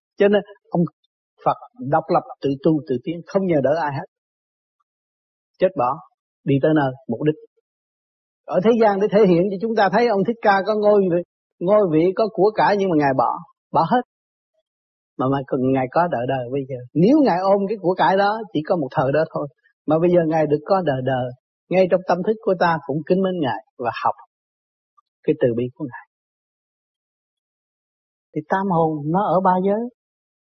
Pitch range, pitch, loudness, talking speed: 150-205 Hz, 175 Hz, -20 LUFS, 200 wpm